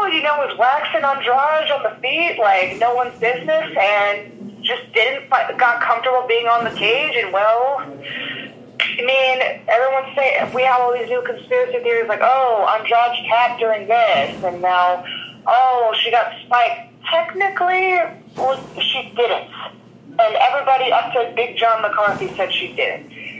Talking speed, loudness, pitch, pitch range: 160 wpm, -17 LUFS, 250 Hz, 230-320 Hz